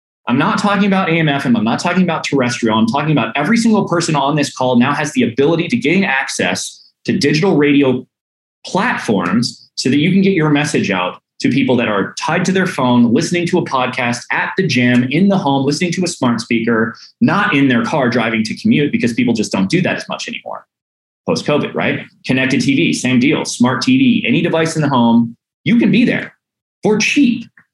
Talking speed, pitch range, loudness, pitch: 210 wpm, 125-190 Hz, -14 LUFS, 150 Hz